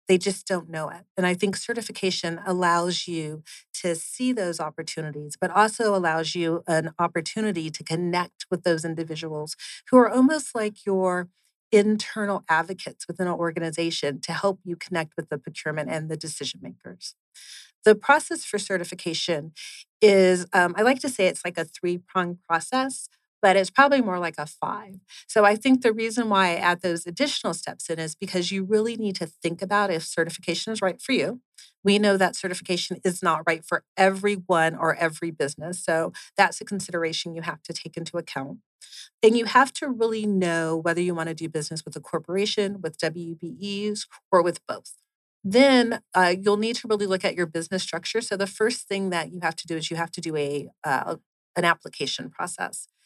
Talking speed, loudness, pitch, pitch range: 190 wpm, -24 LUFS, 180 Hz, 165-205 Hz